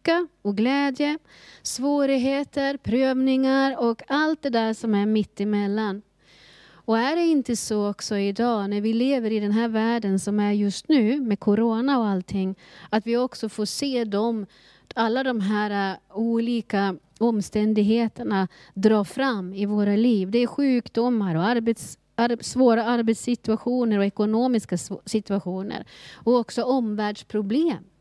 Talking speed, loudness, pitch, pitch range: 135 wpm, -24 LUFS, 225 Hz, 205-245 Hz